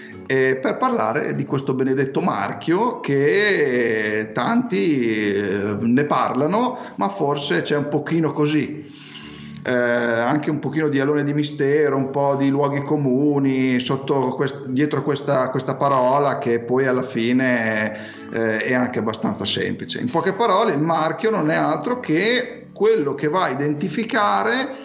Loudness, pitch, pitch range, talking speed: -20 LUFS, 140 Hz, 125-150 Hz, 140 wpm